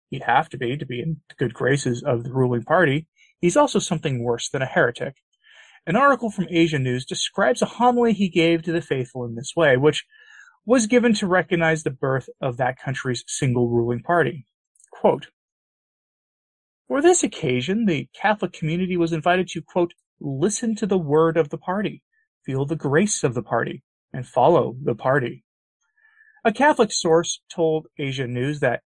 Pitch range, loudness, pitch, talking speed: 135-210 Hz, -22 LUFS, 165 Hz, 175 wpm